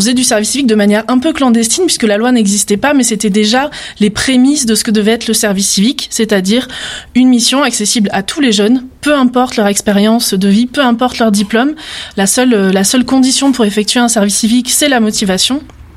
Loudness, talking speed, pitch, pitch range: -10 LUFS, 220 wpm, 235 Hz, 210-255 Hz